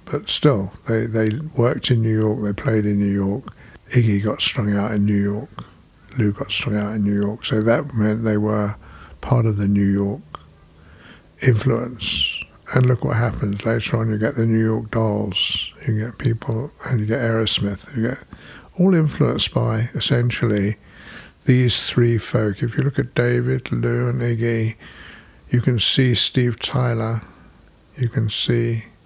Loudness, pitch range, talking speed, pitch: -20 LUFS, 105-120 Hz, 170 wpm, 115 Hz